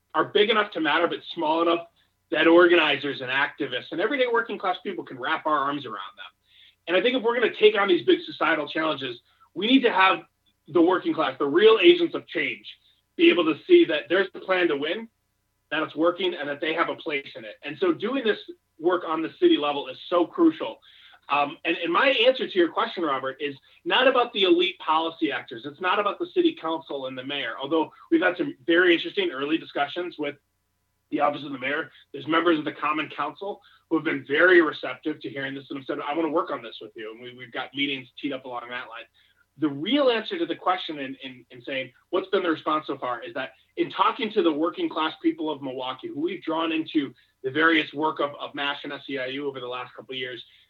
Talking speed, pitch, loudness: 235 wpm, 165 Hz, -24 LUFS